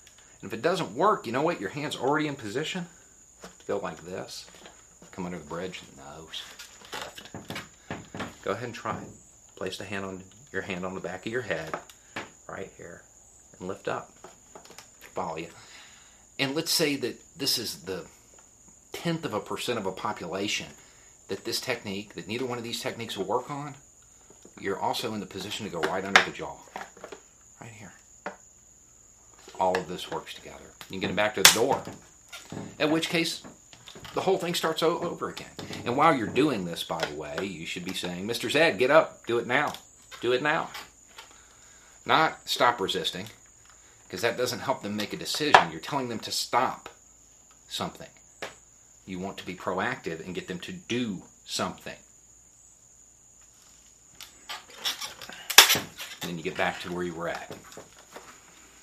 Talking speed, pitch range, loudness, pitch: 170 wpm, 95-145 Hz, -28 LUFS, 115 Hz